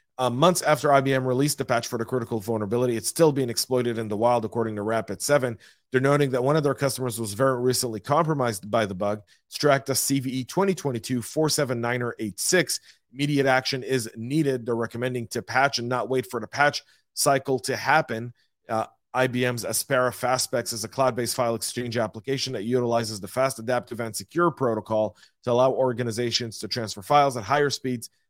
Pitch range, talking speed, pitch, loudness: 115-135 Hz, 170 wpm, 125 Hz, -25 LUFS